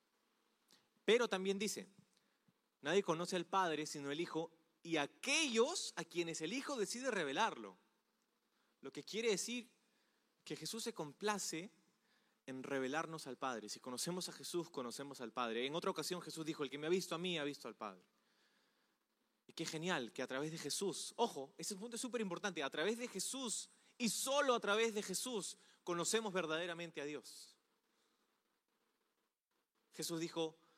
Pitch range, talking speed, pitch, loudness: 155-210 Hz, 160 wpm, 175 Hz, -41 LUFS